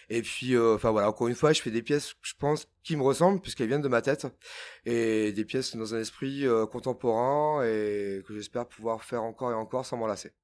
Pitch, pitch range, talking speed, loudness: 120 Hz, 110-135 Hz, 230 wpm, -29 LUFS